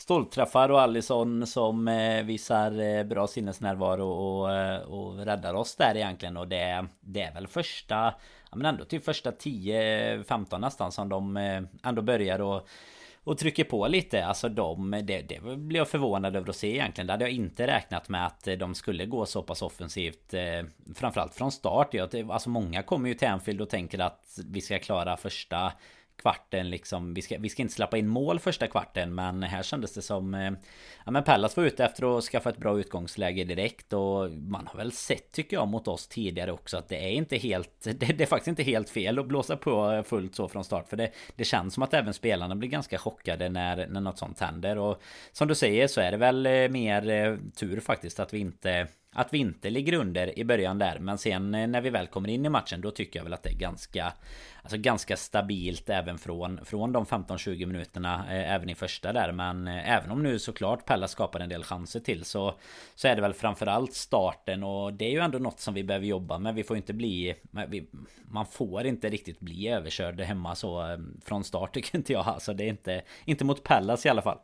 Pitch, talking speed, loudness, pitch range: 100 Hz, 210 wpm, -30 LUFS, 90-115 Hz